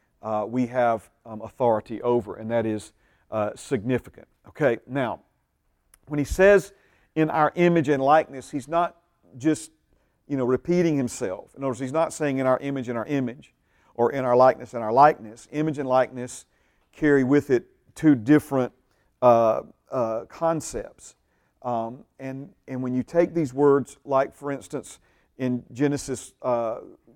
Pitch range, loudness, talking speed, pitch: 115-150 Hz, -24 LUFS, 160 wpm, 130 Hz